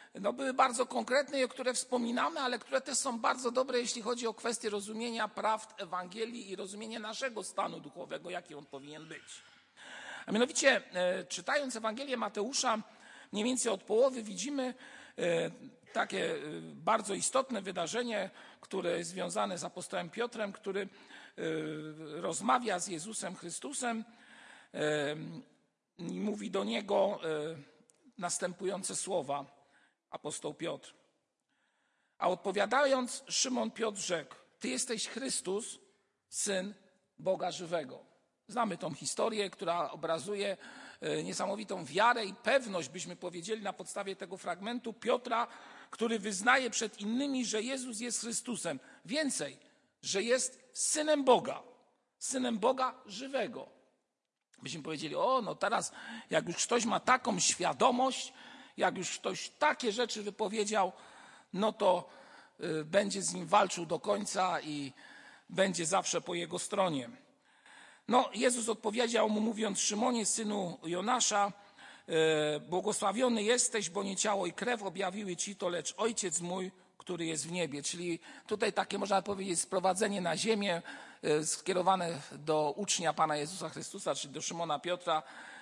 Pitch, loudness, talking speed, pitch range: 205 Hz, -34 LUFS, 125 wpm, 180-240 Hz